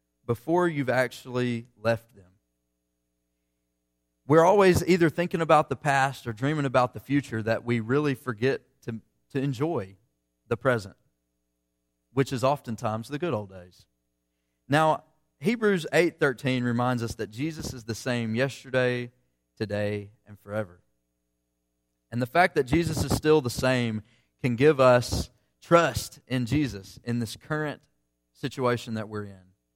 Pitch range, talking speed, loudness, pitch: 90-135 Hz, 140 wpm, -26 LUFS, 120 Hz